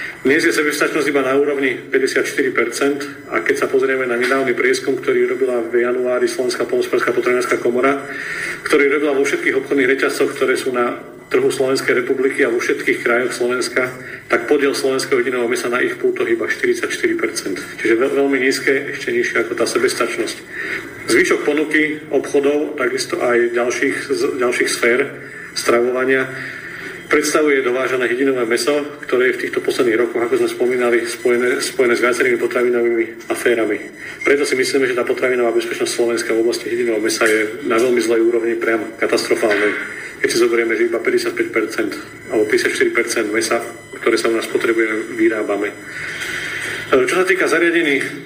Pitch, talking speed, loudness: 365 Hz, 155 wpm, -17 LUFS